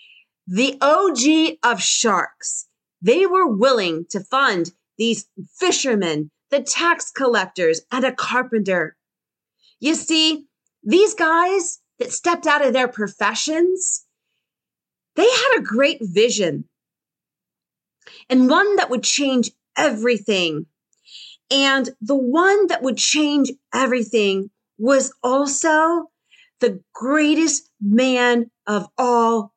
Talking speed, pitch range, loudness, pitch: 105 wpm, 220-315 Hz, -18 LUFS, 260 Hz